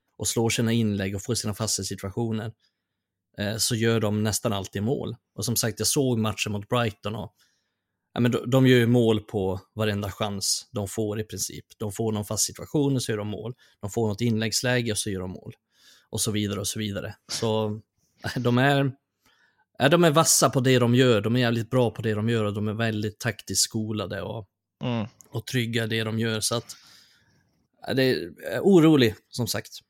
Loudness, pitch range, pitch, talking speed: -25 LUFS, 105-120 Hz, 110 Hz, 215 wpm